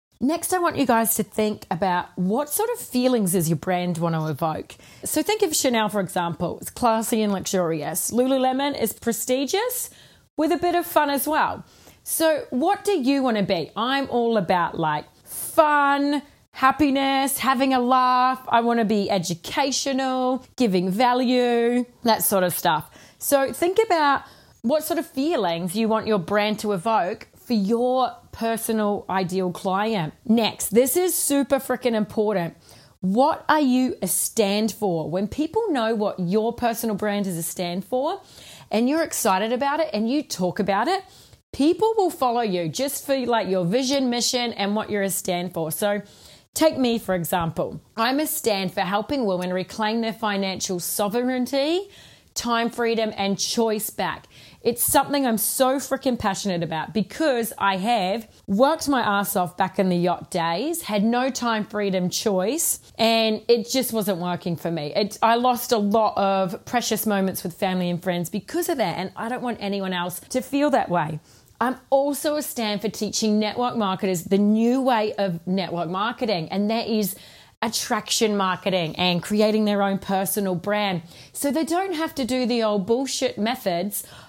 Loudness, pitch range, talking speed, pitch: -23 LUFS, 195-265 Hz, 175 wpm, 225 Hz